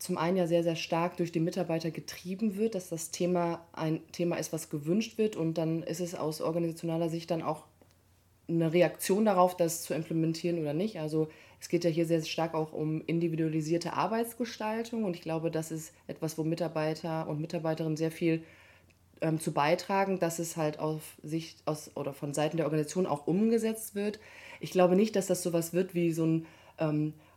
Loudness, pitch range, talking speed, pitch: -32 LUFS, 160-175 Hz, 195 wpm, 165 Hz